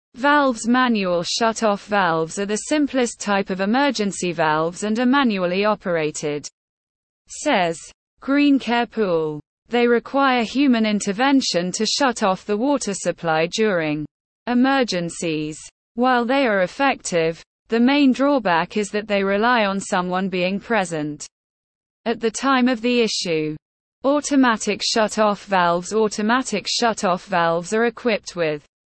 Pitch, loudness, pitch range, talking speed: 210 Hz, -20 LUFS, 175-245 Hz, 125 wpm